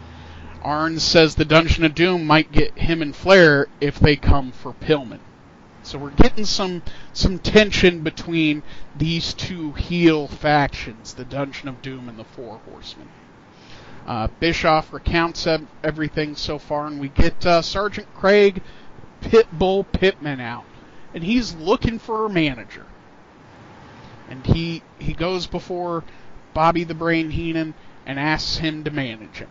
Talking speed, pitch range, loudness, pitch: 145 wpm, 140-170 Hz, -20 LUFS, 155 Hz